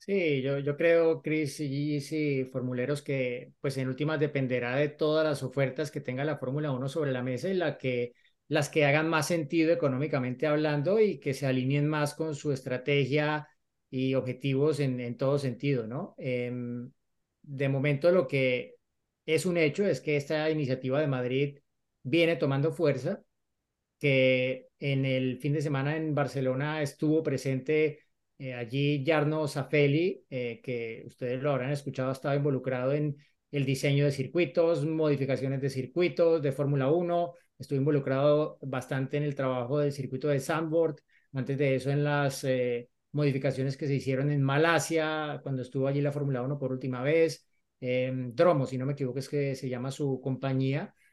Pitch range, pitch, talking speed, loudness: 130-155 Hz, 140 Hz, 175 wpm, -29 LUFS